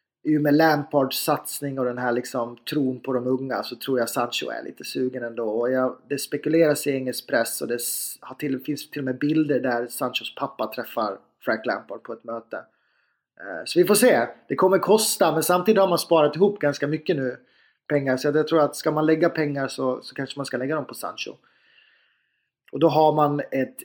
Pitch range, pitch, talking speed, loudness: 130-155 Hz, 145 Hz, 205 wpm, -23 LUFS